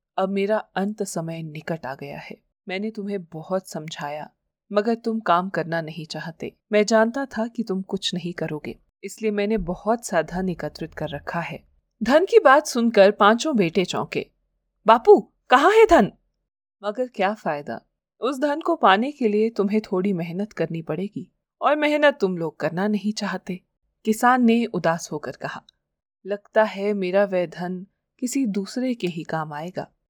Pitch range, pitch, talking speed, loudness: 170-220 Hz, 195 Hz, 165 wpm, -22 LUFS